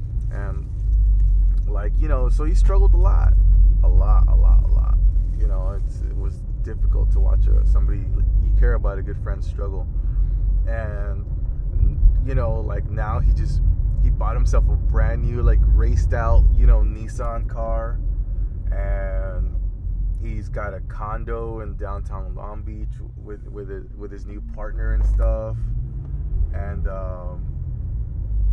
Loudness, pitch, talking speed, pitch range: -23 LUFS, 95 Hz, 150 wpm, 85-105 Hz